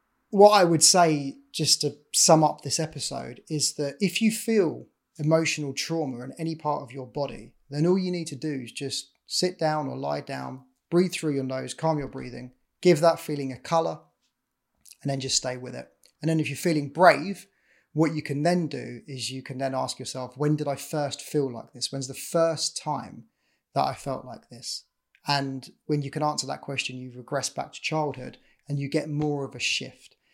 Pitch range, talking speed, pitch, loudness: 135-160 Hz, 210 wpm, 145 Hz, -26 LUFS